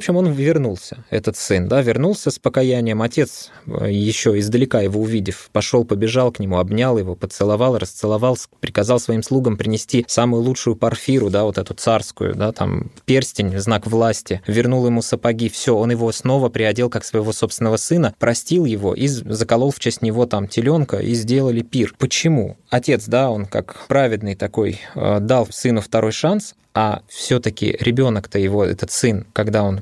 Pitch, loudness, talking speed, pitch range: 115 Hz, -18 LUFS, 165 wpm, 105-125 Hz